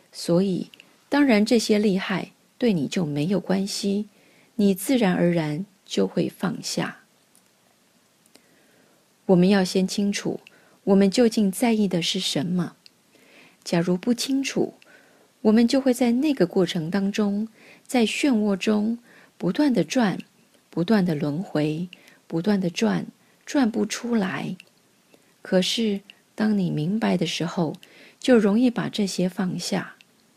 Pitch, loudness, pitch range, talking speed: 200 Hz, -23 LUFS, 185-230 Hz, 185 characters per minute